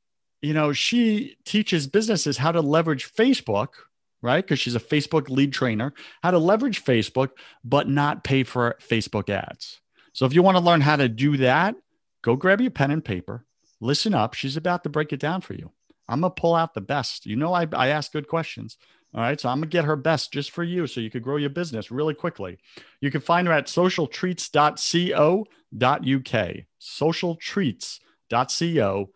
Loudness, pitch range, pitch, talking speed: -23 LUFS, 130-170 Hz, 150 Hz, 185 wpm